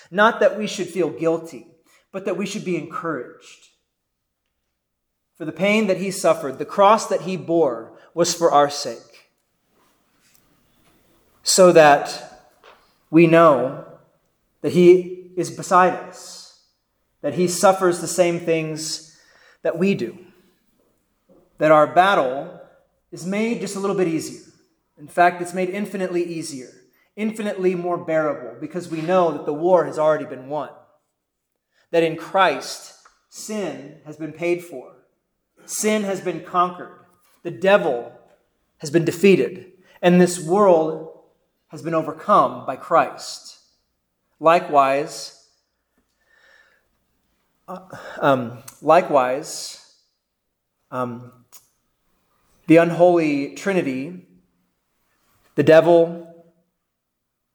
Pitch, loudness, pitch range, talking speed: 170 Hz, -19 LUFS, 155-180 Hz, 115 wpm